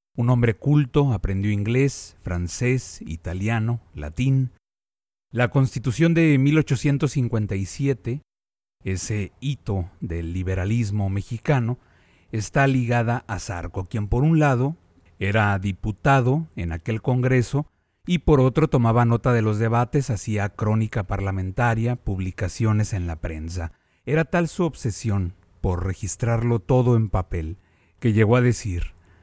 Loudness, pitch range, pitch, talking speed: -23 LUFS, 95-130 Hz, 115 Hz, 120 wpm